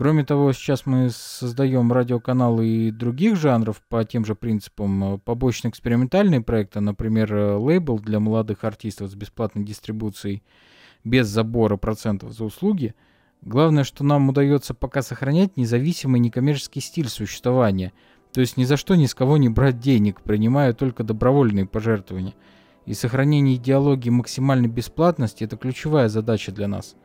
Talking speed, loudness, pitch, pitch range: 140 wpm, -21 LUFS, 120 Hz, 110-135 Hz